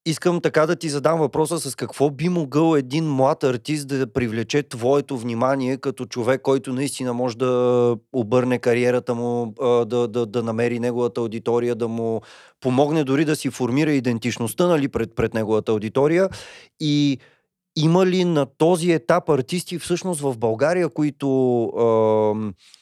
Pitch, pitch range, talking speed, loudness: 130 Hz, 120-155 Hz, 145 wpm, -21 LUFS